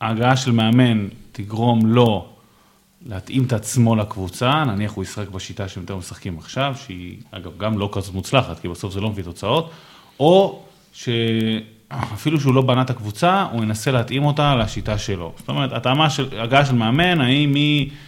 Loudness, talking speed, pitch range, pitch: -19 LUFS, 165 wpm, 105-135 Hz, 115 Hz